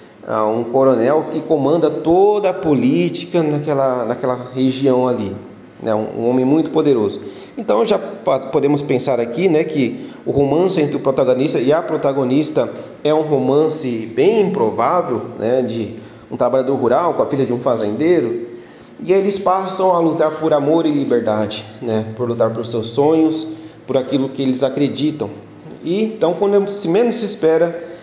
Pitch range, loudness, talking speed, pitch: 125-160 Hz, -17 LUFS, 160 wpm, 145 Hz